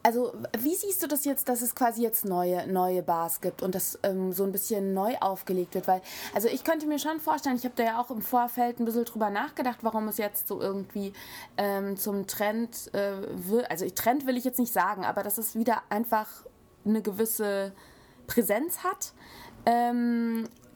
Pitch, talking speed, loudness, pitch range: 225 Hz, 195 wpm, -29 LUFS, 195-245 Hz